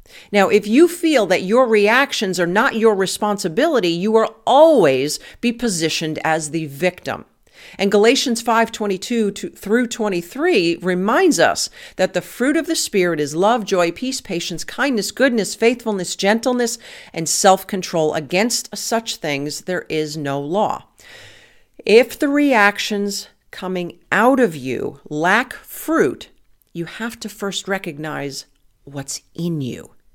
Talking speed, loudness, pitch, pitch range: 130 wpm, -18 LUFS, 205 Hz, 170-235 Hz